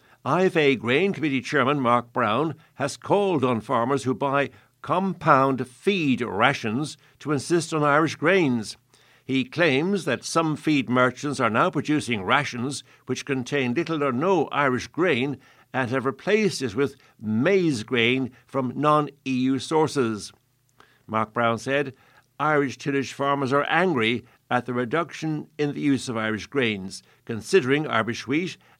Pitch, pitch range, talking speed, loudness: 135 Hz, 125-150 Hz, 140 wpm, -24 LUFS